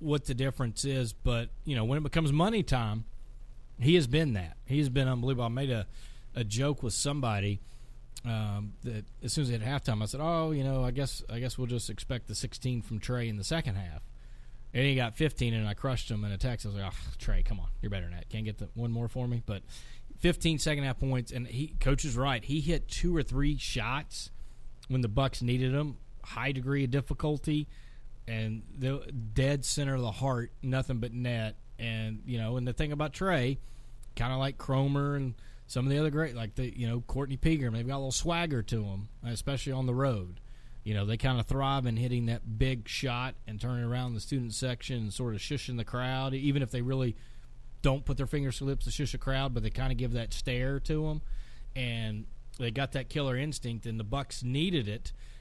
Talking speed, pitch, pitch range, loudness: 230 wpm, 125 Hz, 115-135 Hz, -33 LUFS